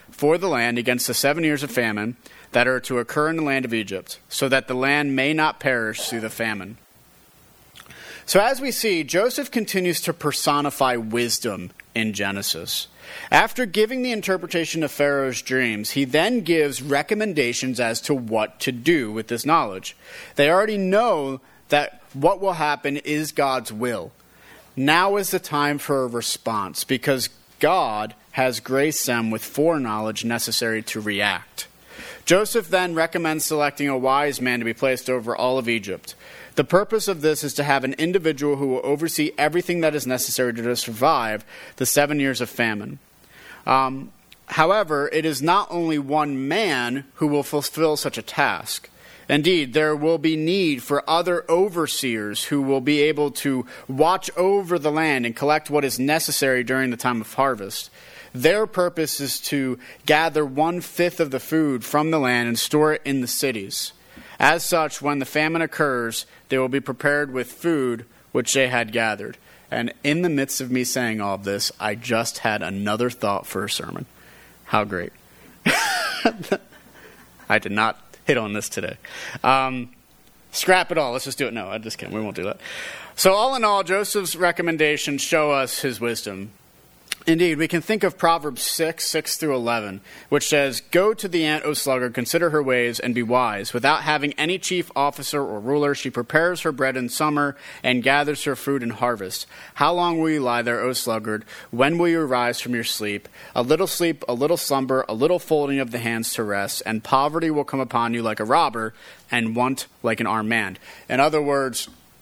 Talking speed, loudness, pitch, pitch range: 180 wpm, -22 LUFS, 140 Hz, 120-155 Hz